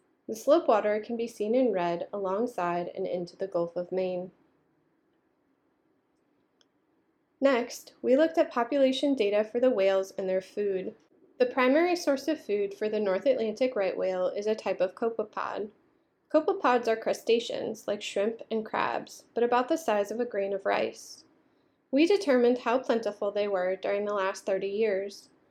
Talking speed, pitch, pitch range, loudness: 165 wpm, 235 Hz, 200-305 Hz, -28 LUFS